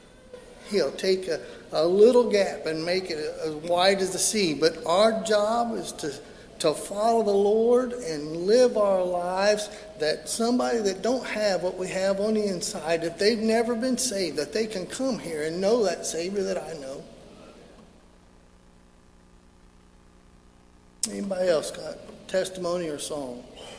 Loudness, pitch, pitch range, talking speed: -25 LUFS, 190 Hz, 155-220 Hz, 155 wpm